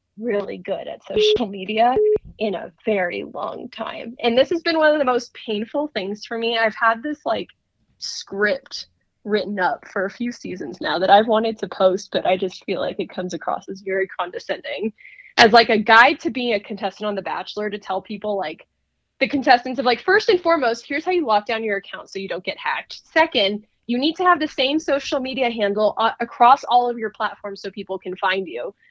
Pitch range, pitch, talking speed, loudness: 200-260 Hz, 220 Hz, 220 wpm, -20 LUFS